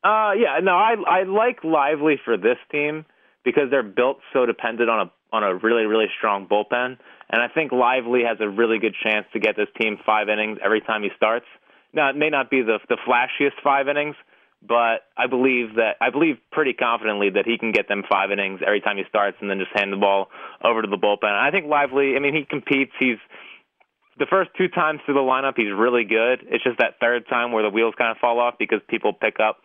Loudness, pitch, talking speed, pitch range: -21 LUFS, 120 Hz, 235 wpm, 105-140 Hz